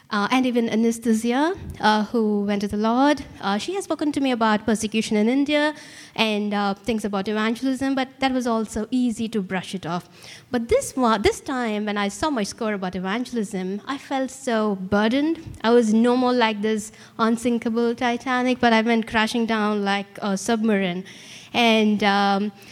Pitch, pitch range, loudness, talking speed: 225 Hz, 210-250 Hz, -22 LUFS, 180 wpm